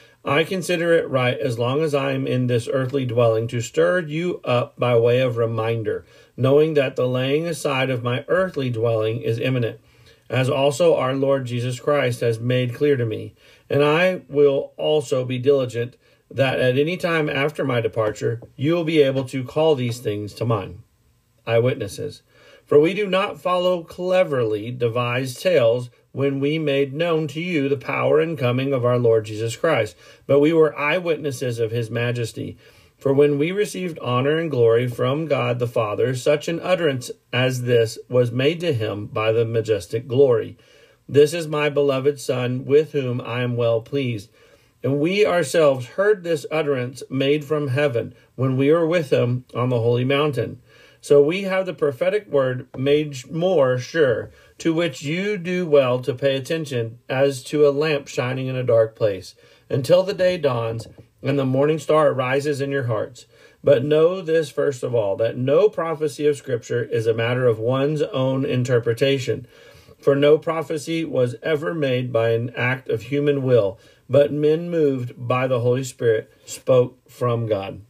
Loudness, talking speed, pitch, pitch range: -21 LUFS, 175 wpm, 135 Hz, 120-150 Hz